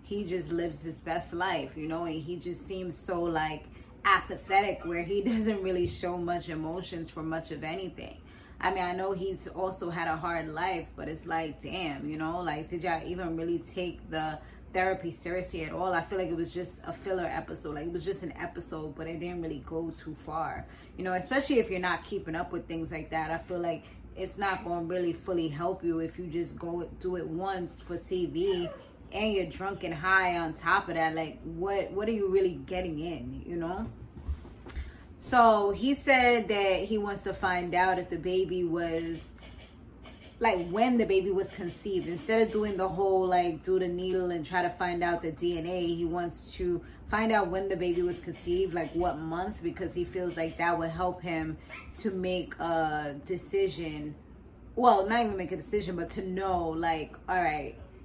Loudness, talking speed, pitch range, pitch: -31 LUFS, 205 wpm, 165-185 Hz, 175 Hz